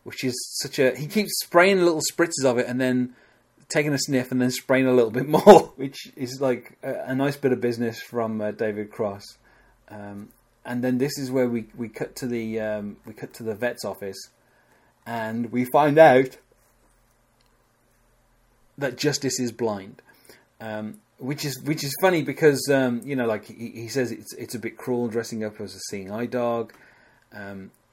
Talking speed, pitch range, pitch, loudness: 190 wpm, 115-135 Hz, 125 Hz, -23 LUFS